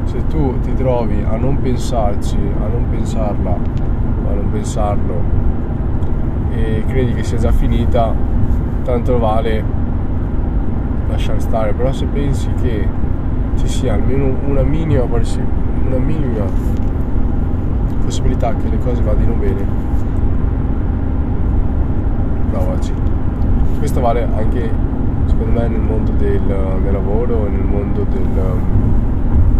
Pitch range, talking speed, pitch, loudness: 85-115 Hz, 110 wpm, 100 Hz, -18 LUFS